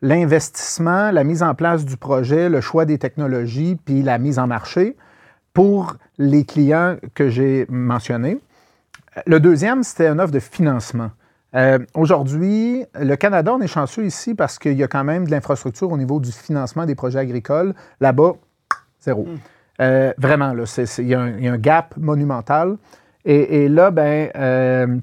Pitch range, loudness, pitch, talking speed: 130-170 Hz, -18 LUFS, 145 Hz, 165 wpm